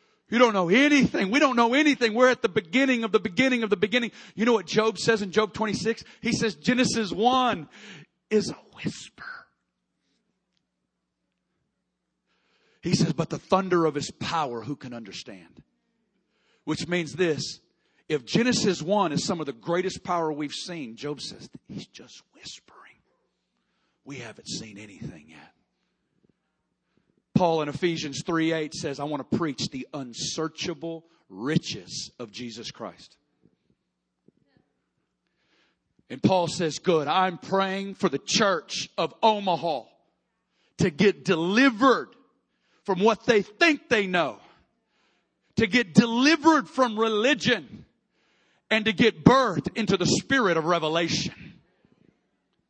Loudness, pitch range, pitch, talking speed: -24 LUFS, 160-225 Hz, 190 Hz, 135 wpm